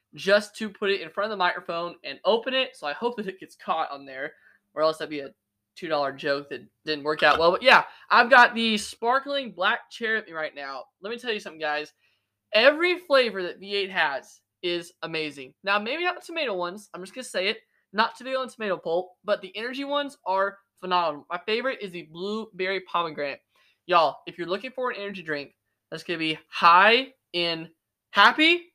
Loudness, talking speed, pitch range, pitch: -24 LUFS, 215 wpm, 160-230 Hz, 185 Hz